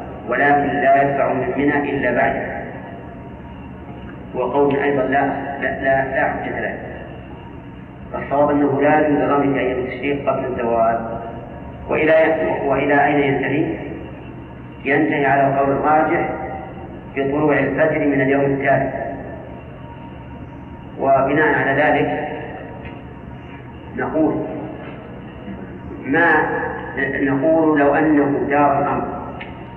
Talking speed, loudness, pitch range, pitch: 90 wpm, -18 LUFS, 125-145 Hz, 140 Hz